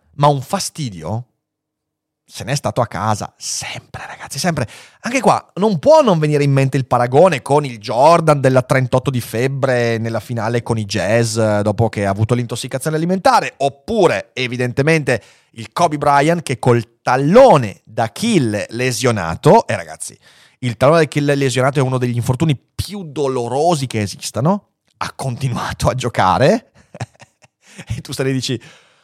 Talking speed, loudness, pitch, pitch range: 155 wpm, -16 LUFS, 130 Hz, 115-150 Hz